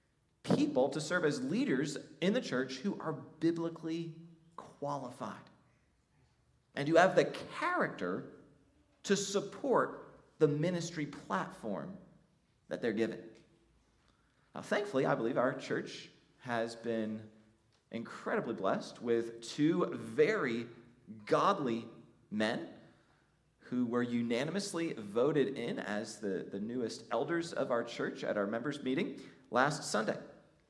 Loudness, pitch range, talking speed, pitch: -35 LUFS, 115-165 Hz, 115 wpm, 145 Hz